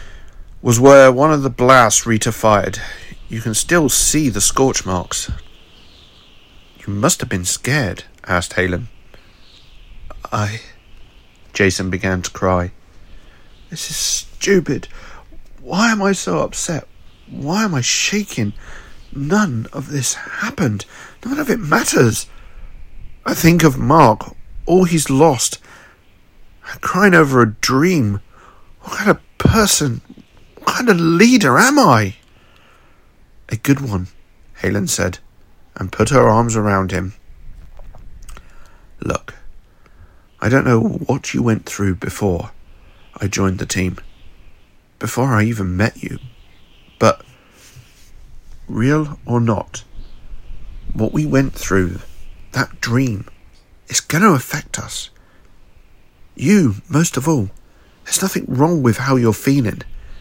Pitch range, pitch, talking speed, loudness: 90-135 Hz, 110 Hz, 125 wpm, -16 LUFS